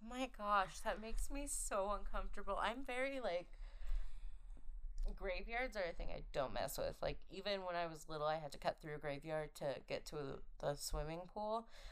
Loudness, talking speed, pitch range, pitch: -45 LUFS, 185 wpm, 160-225 Hz, 195 Hz